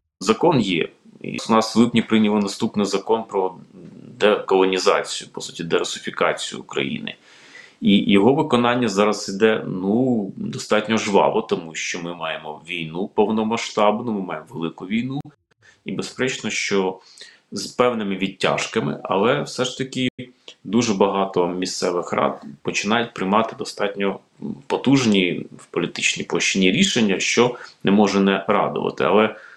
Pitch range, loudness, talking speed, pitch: 95-115 Hz, -21 LUFS, 125 wpm, 105 Hz